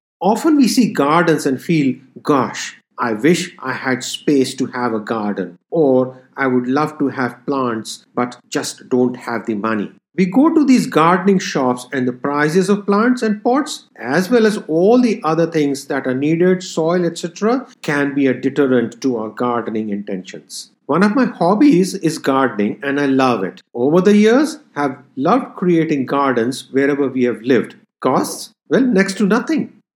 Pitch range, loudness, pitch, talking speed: 125-205 Hz, -17 LUFS, 145 Hz, 175 wpm